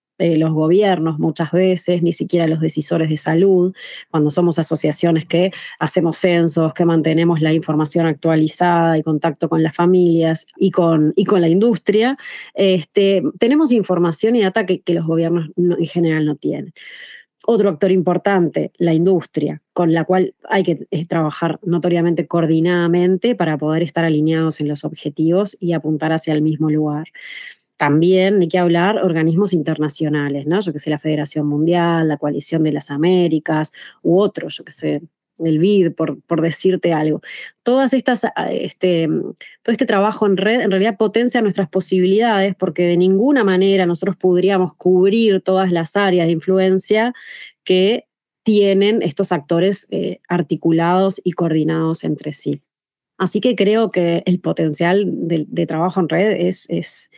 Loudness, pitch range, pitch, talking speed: -17 LUFS, 160-190 Hz, 175 Hz, 155 wpm